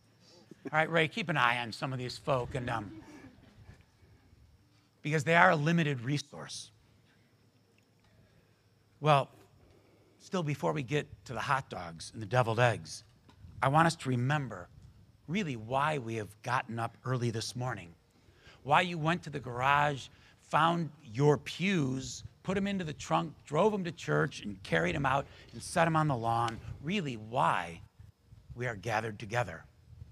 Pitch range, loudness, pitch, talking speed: 110-145 Hz, -32 LUFS, 120 Hz, 160 wpm